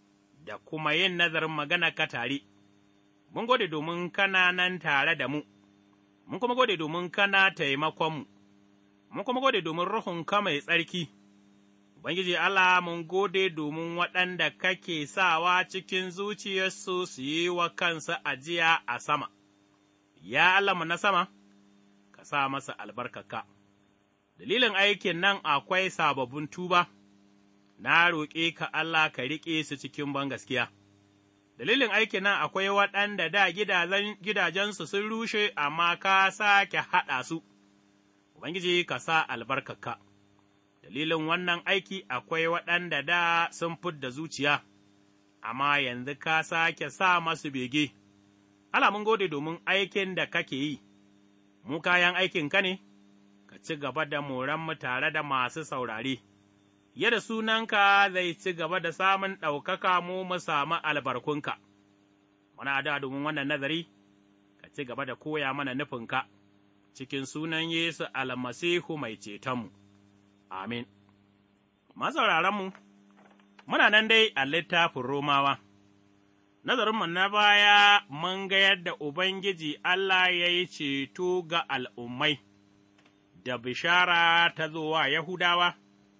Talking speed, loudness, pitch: 120 wpm, -27 LUFS, 155 Hz